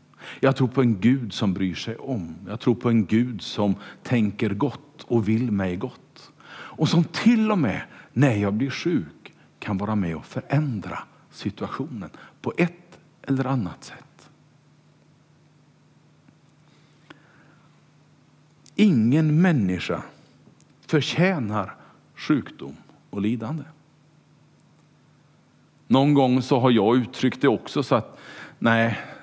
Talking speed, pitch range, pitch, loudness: 120 wpm, 115-150 Hz, 140 Hz, -23 LUFS